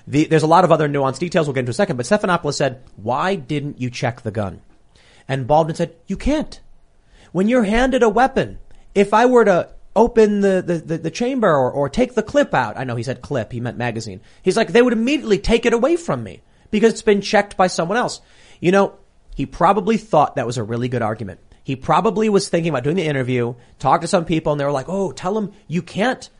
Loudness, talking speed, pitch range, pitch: -18 LUFS, 240 wpm, 135-210 Hz, 170 Hz